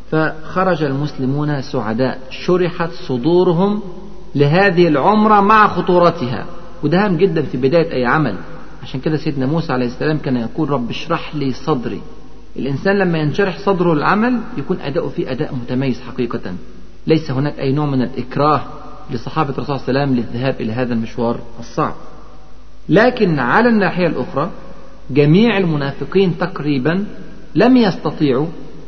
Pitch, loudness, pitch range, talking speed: 150 Hz, -16 LUFS, 130-180 Hz, 135 wpm